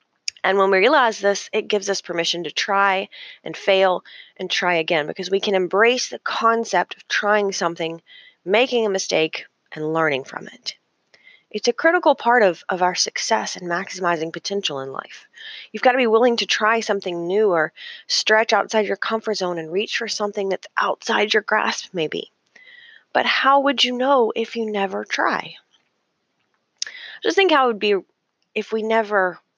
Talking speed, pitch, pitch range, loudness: 175 wpm, 205 Hz, 185-230 Hz, -20 LUFS